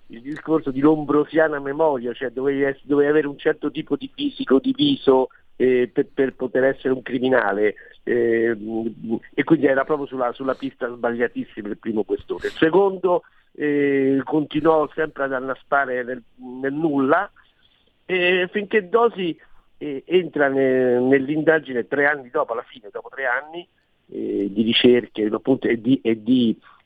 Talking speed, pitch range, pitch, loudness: 155 wpm, 125-155 Hz, 140 Hz, -21 LUFS